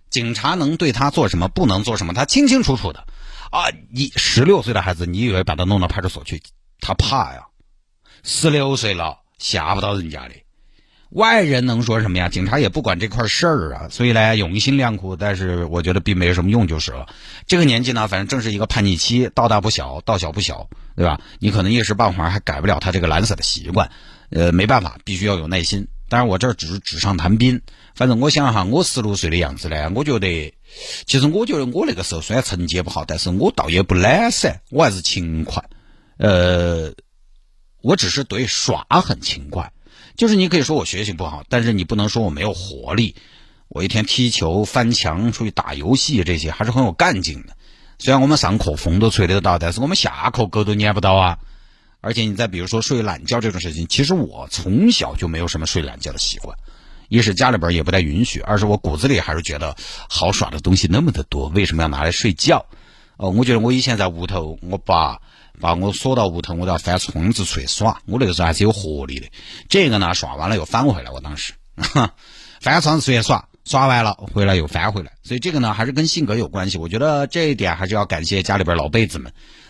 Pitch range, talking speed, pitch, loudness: 90-120 Hz, 330 characters per minute, 100 Hz, -18 LUFS